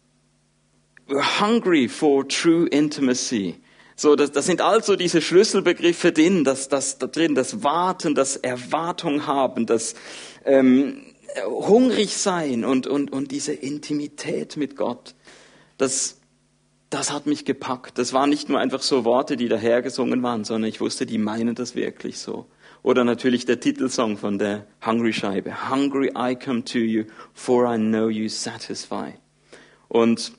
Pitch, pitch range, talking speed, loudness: 135 Hz, 115-150 Hz, 150 wpm, -22 LUFS